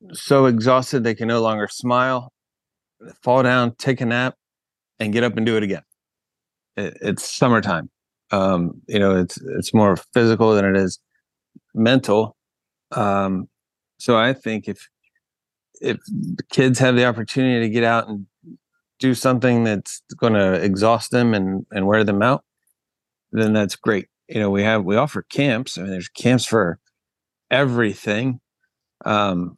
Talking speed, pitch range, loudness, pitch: 155 wpm, 100-125 Hz, -19 LUFS, 115 Hz